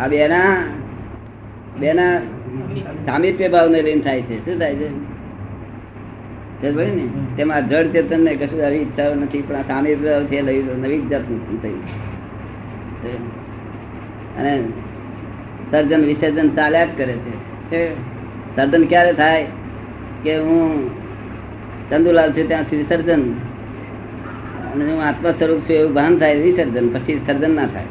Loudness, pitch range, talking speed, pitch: -17 LUFS, 115-155 Hz, 110 wpm, 135 Hz